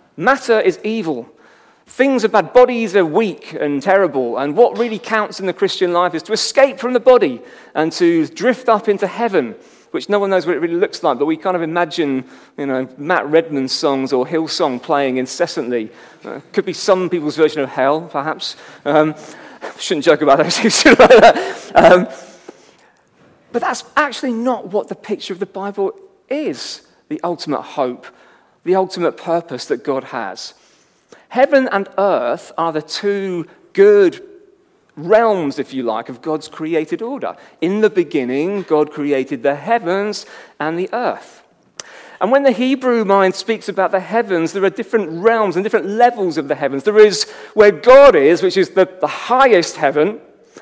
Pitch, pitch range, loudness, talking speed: 190 Hz, 155-230 Hz, -15 LUFS, 170 wpm